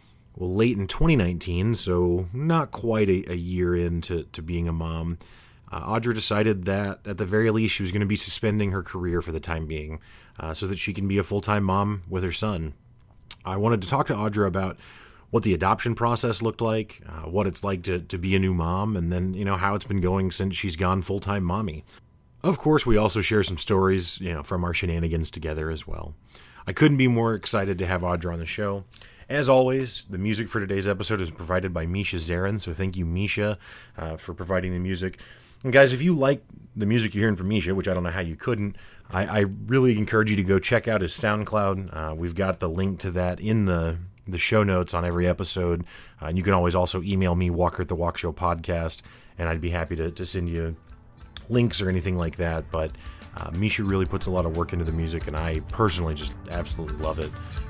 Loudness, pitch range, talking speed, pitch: -25 LUFS, 85-105 Hz, 230 wpm, 95 Hz